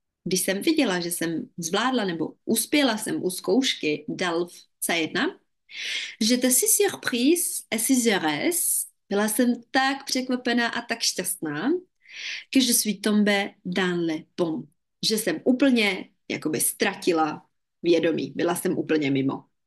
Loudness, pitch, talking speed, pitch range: -24 LUFS, 215 Hz, 120 wpm, 175-255 Hz